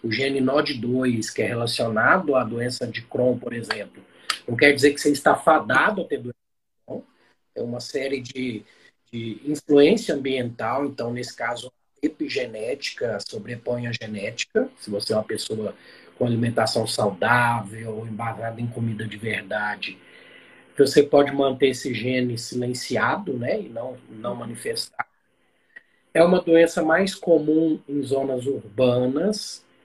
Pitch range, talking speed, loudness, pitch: 115-145 Hz, 135 wpm, -23 LUFS, 125 Hz